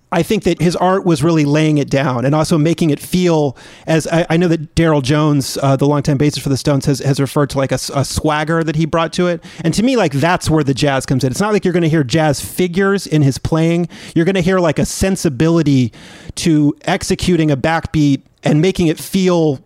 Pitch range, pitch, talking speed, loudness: 145-175 Hz, 160 Hz, 240 wpm, -15 LUFS